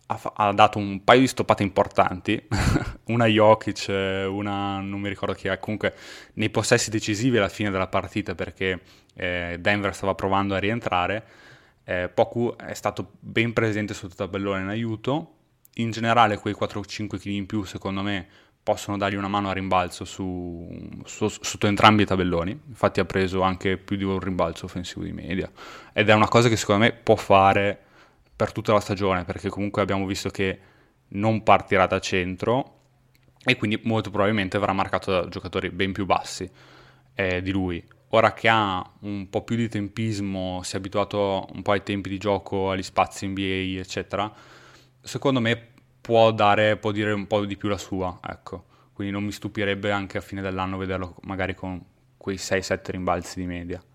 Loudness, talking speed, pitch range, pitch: -24 LUFS, 180 wpm, 95-110 Hz, 100 Hz